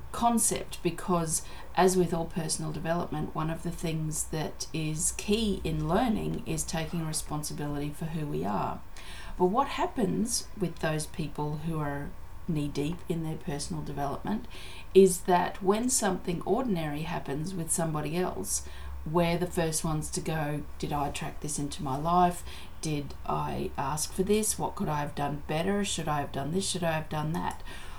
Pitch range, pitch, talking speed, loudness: 150-180 Hz, 165 Hz, 170 wpm, -30 LUFS